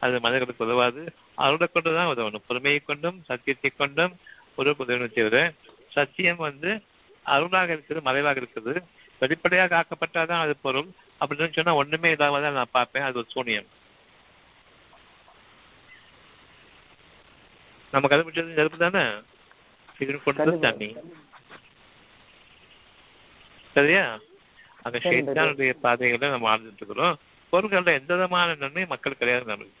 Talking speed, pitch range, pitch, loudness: 105 wpm, 130-165 Hz, 145 Hz, -24 LUFS